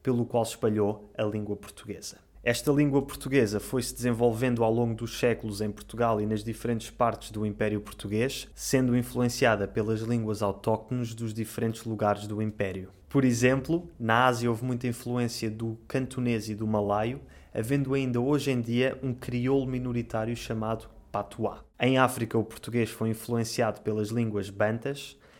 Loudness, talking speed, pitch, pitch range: -29 LUFS, 155 wpm, 115 Hz, 110-125 Hz